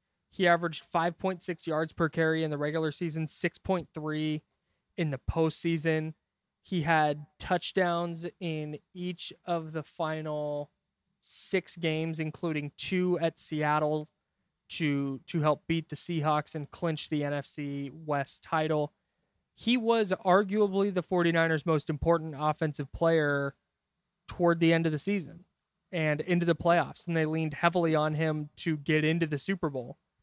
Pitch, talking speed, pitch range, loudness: 160 Hz, 140 wpm, 150-175 Hz, -30 LUFS